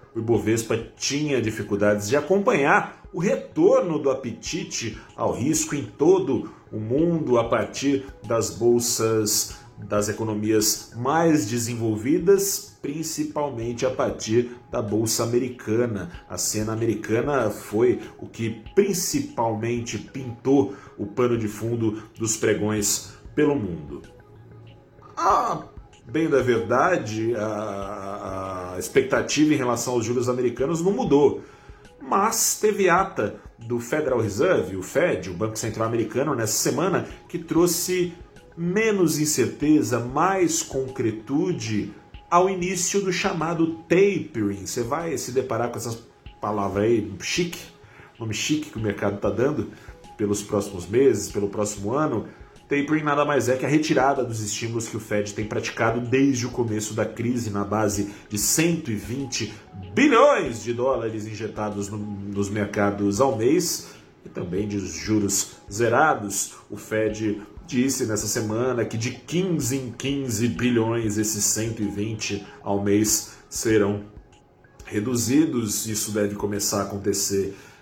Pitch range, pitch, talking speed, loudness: 105-135 Hz, 115 Hz, 130 wpm, -23 LUFS